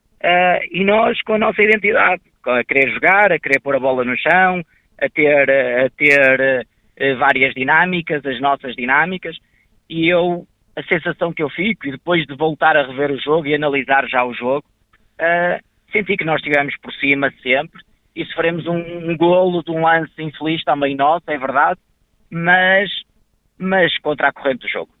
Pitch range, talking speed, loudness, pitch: 135-175 Hz, 180 wpm, -16 LUFS, 155 Hz